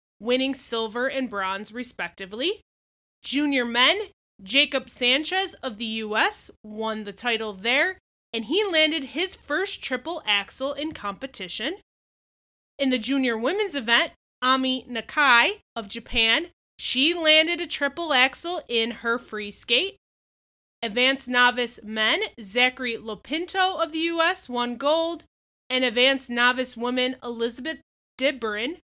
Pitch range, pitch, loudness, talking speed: 230-310 Hz, 255 Hz, -23 LUFS, 125 wpm